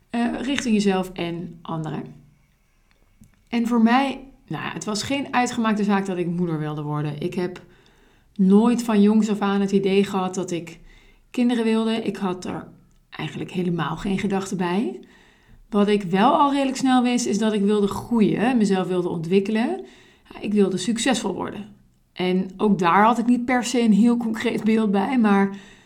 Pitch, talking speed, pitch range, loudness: 205 Hz, 175 wpm, 185-235 Hz, -22 LUFS